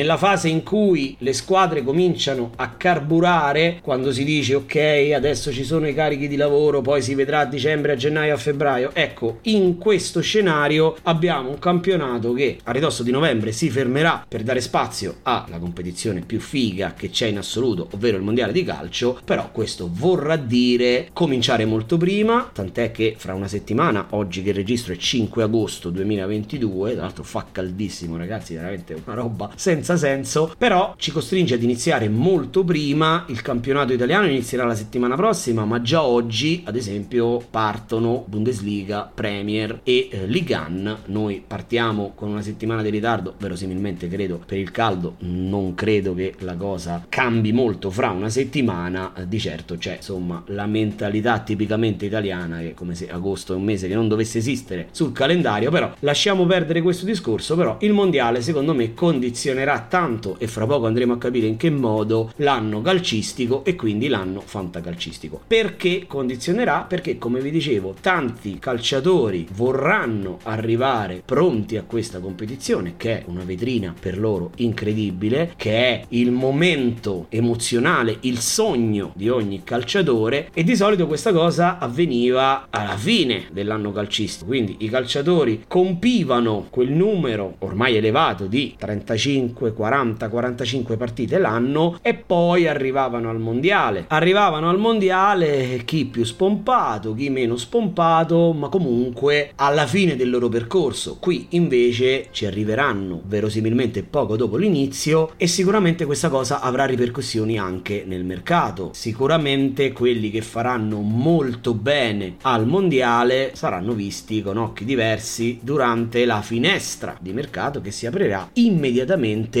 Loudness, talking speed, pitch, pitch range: -21 LUFS, 150 wpm, 120 Hz, 105-150 Hz